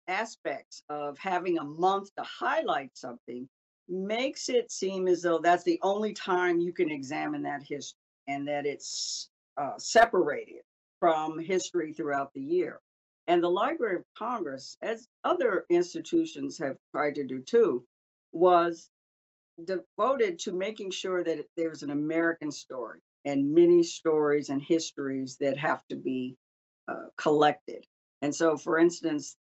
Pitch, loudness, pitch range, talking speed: 170 Hz, -29 LUFS, 145-200 Hz, 145 wpm